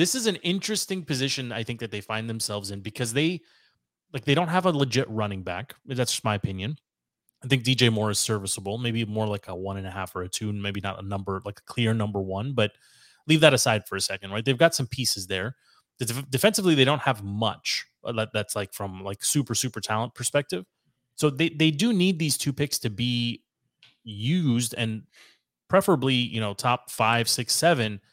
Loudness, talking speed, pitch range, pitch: -25 LUFS, 205 wpm, 105-140 Hz, 115 Hz